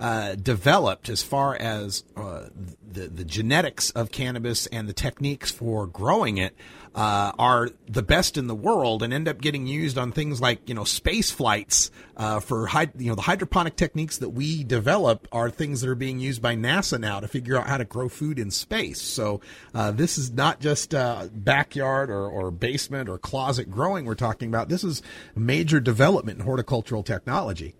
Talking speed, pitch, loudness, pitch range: 190 wpm, 125 Hz, -25 LUFS, 110-140 Hz